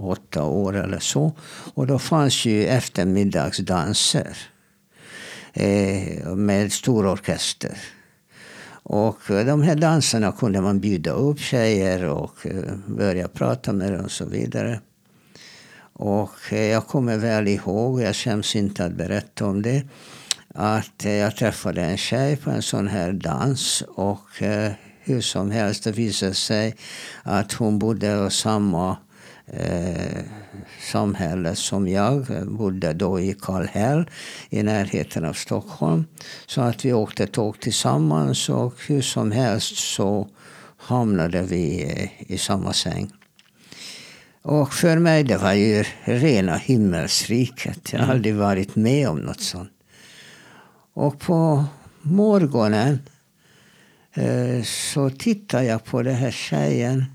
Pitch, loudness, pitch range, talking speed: 110 Hz, -22 LUFS, 100-130 Hz, 130 wpm